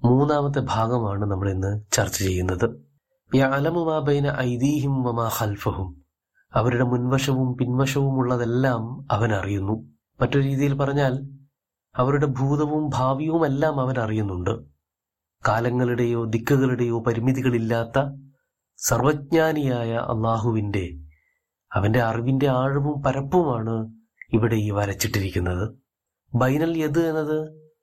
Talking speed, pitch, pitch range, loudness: 80 wpm, 125 Hz, 110-140 Hz, -23 LUFS